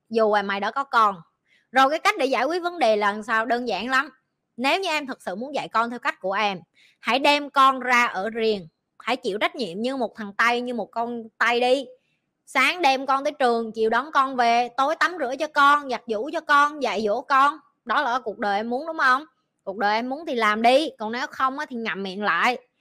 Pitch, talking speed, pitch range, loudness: 245 Hz, 245 wpm, 220-275 Hz, -22 LUFS